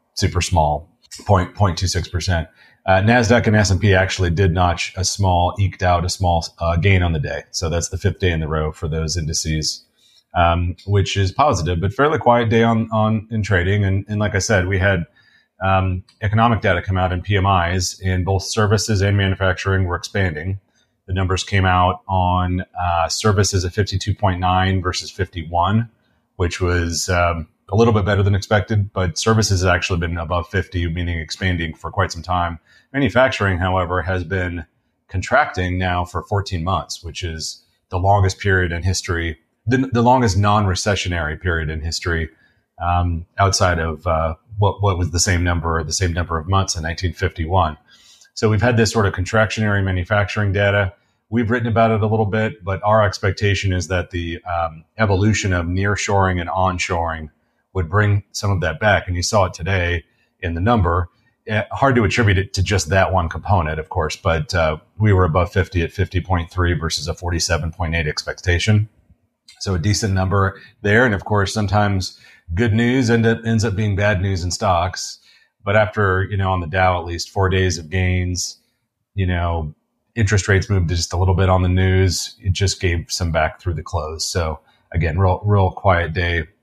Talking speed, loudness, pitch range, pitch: 185 wpm, -19 LUFS, 85-100 Hz, 95 Hz